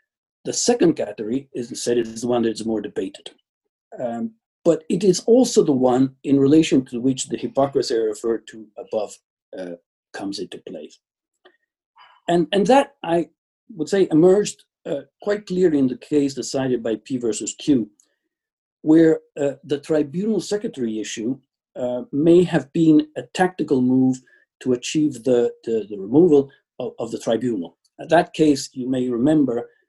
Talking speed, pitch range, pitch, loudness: 160 wpm, 125-205 Hz, 150 Hz, -20 LUFS